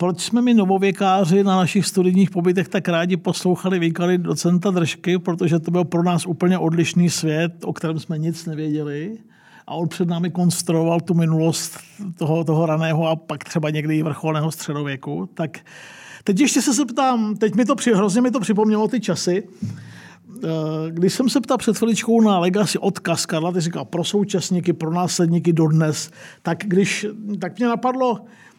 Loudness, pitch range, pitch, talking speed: -20 LUFS, 165-200 Hz, 180 Hz, 170 wpm